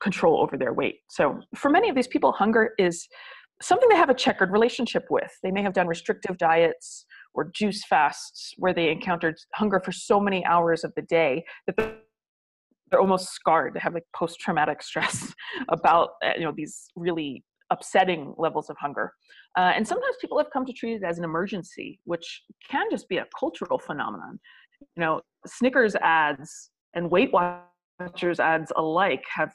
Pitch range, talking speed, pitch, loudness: 170-230 Hz, 175 wpm, 185 Hz, -25 LUFS